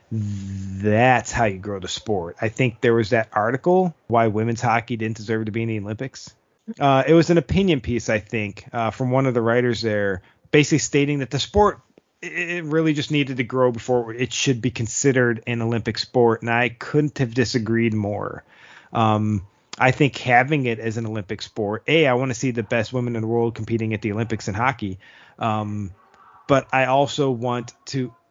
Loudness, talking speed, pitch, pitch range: -21 LUFS, 200 wpm, 120 Hz, 110-130 Hz